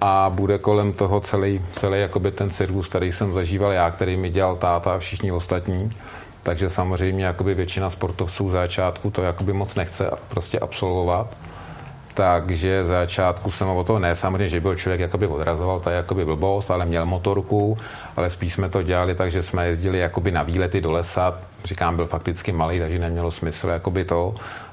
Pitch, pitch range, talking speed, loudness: 95 Hz, 90-100 Hz, 170 wpm, -23 LUFS